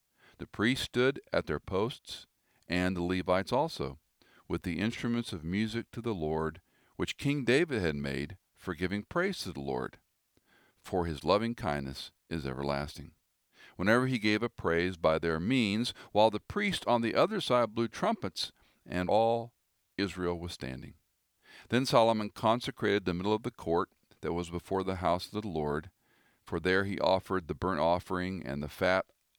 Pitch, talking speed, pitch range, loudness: 95 Hz, 170 wpm, 85-115 Hz, -32 LUFS